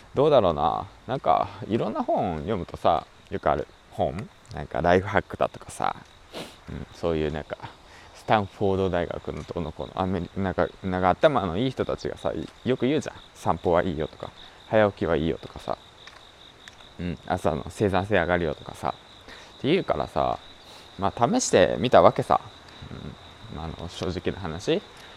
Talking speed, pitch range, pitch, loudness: 310 characters per minute, 85-100 Hz, 90 Hz, -26 LUFS